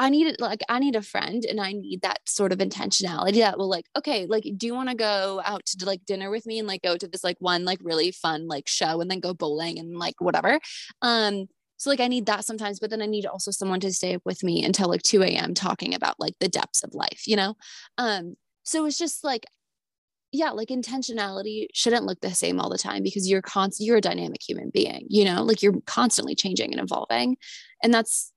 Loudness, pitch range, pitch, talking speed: -25 LUFS, 185-230 Hz, 200 Hz, 240 wpm